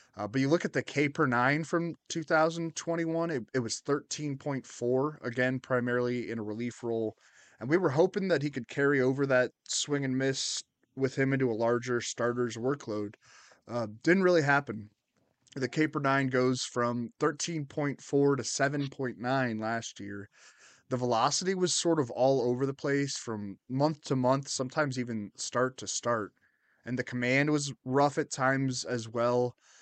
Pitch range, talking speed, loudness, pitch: 120-145 Hz, 160 wpm, -30 LUFS, 130 Hz